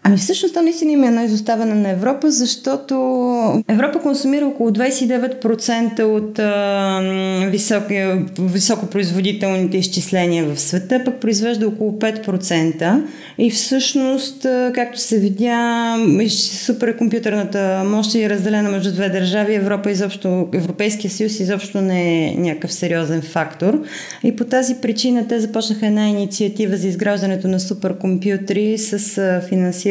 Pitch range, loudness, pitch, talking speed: 190-235 Hz, -17 LUFS, 210 Hz, 120 wpm